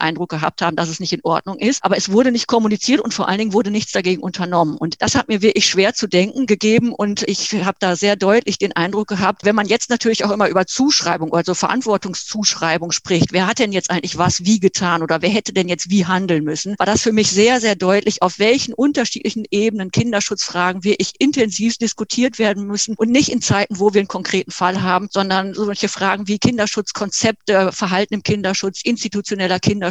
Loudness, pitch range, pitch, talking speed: -17 LUFS, 185-220 Hz, 200 Hz, 215 wpm